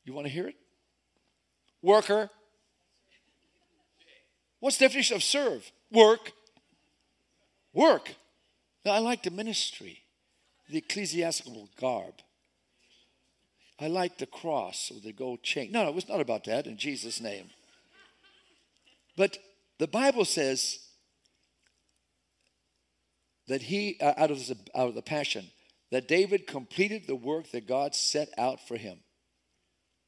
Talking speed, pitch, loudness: 130 wpm, 155 Hz, -29 LUFS